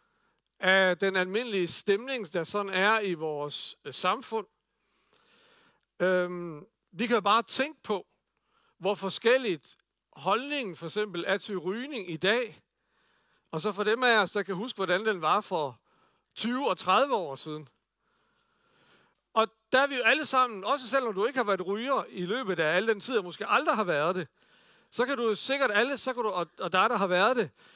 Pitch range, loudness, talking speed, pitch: 185-255 Hz, -28 LUFS, 185 wpm, 215 Hz